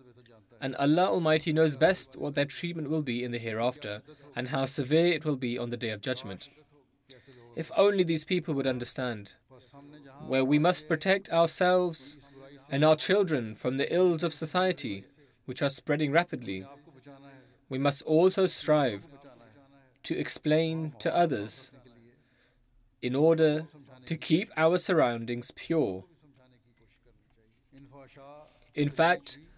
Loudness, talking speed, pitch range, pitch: -28 LUFS, 130 wpm, 125-160 Hz, 140 Hz